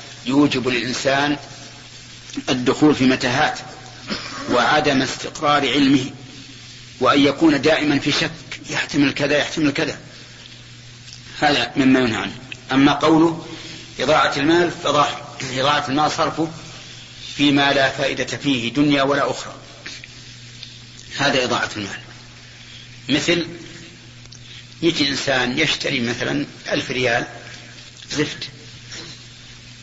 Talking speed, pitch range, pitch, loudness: 95 wpm, 120-145 Hz, 135 Hz, -18 LUFS